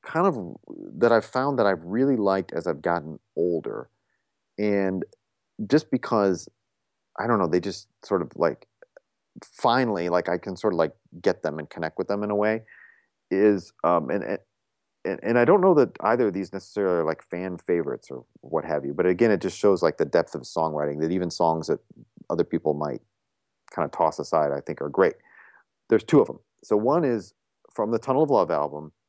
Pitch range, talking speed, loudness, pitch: 85-110 Hz, 205 wpm, -25 LUFS, 95 Hz